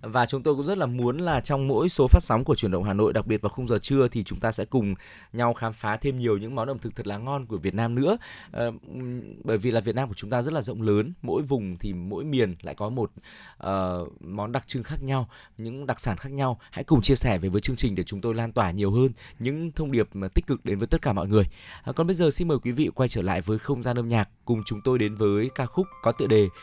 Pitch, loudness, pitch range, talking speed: 115 Hz, -26 LUFS, 105-135 Hz, 285 wpm